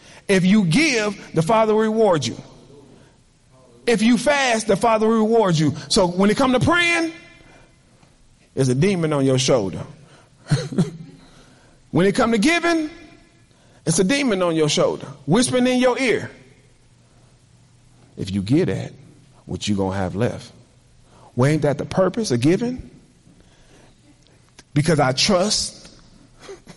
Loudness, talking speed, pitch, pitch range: -19 LUFS, 140 wpm, 155 Hz, 130-220 Hz